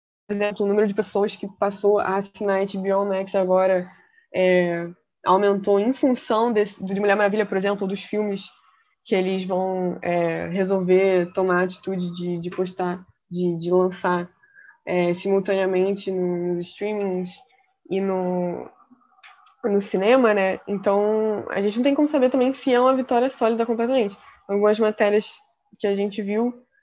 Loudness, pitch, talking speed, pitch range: -22 LUFS, 200 Hz, 150 wpm, 185-215 Hz